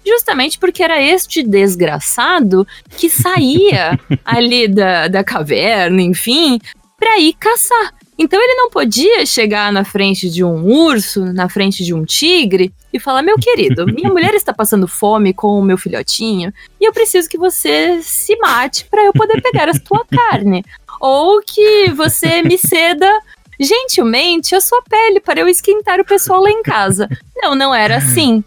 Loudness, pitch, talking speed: -11 LUFS, 315 Hz, 165 wpm